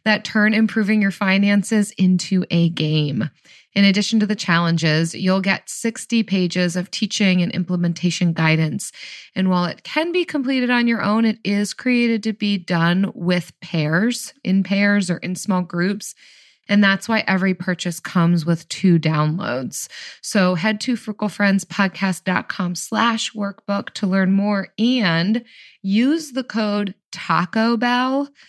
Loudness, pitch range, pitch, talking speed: -19 LUFS, 180-220 Hz, 200 Hz, 145 wpm